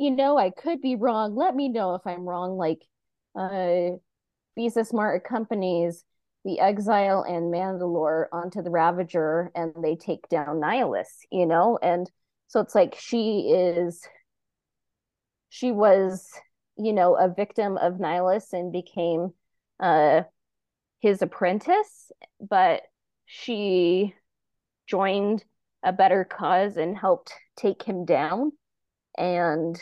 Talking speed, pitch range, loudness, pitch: 125 wpm, 175-215 Hz, -25 LUFS, 185 Hz